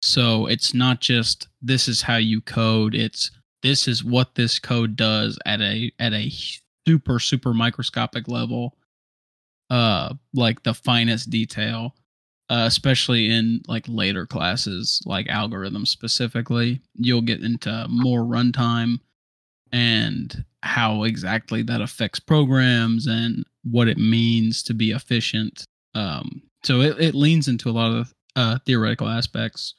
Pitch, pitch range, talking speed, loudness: 115 Hz, 110-125 Hz, 135 wpm, -21 LUFS